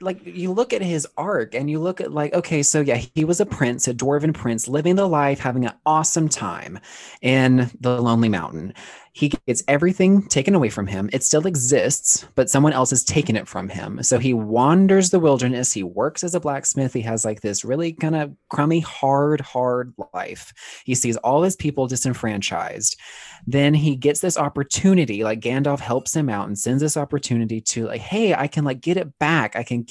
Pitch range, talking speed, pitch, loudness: 120-155 Hz, 205 wpm, 140 Hz, -20 LUFS